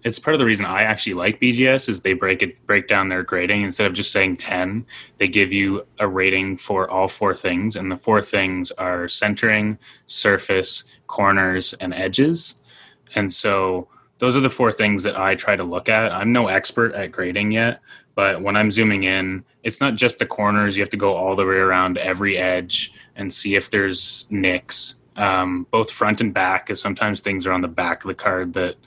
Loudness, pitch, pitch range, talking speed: -19 LUFS, 100 Hz, 95-110 Hz, 210 wpm